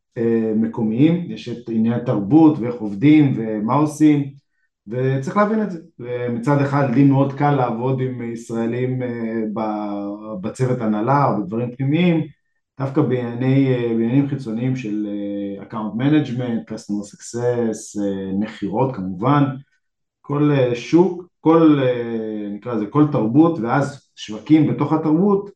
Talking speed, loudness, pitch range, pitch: 115 wpm, -19 LUFS, 110-145 Hz, 125 Hz